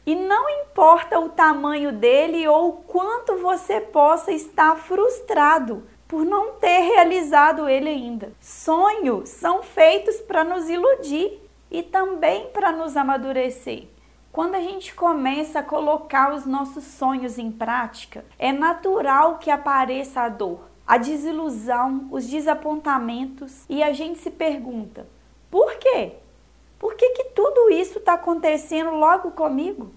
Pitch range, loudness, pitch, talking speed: 275-365 Hz, -20 LUFS, 315 Hz, 135 wpm